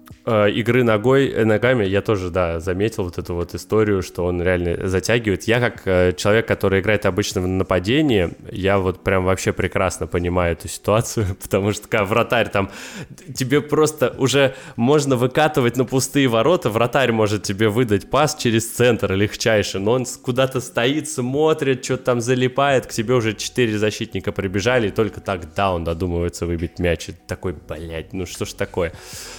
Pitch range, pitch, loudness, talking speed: 95-125 Hz, 105 Hz, -19 LUFS, 165 wpm